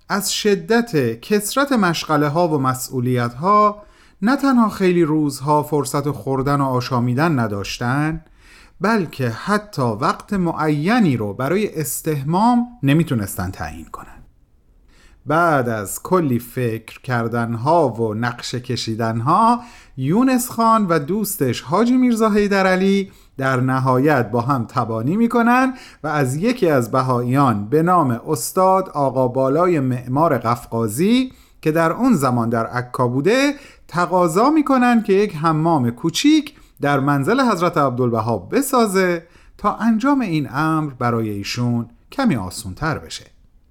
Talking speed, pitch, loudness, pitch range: 120 wpm, 150 Hz, -18 LUFS, 125-200 Hz